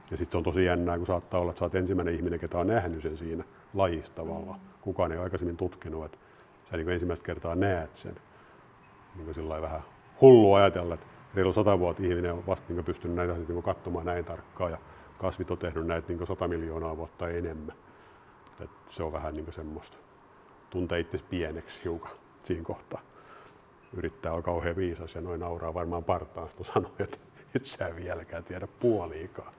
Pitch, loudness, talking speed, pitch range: 85 Hz, -30 LUFS, 180 wpm, 85-90 Hz